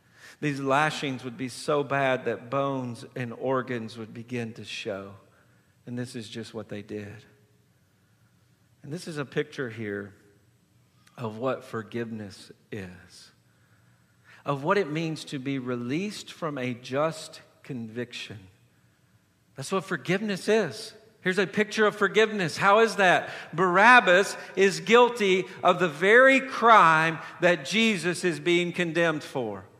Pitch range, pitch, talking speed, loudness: 115-180 Hz, 140 Hz, 135 wpm, -24 LUFS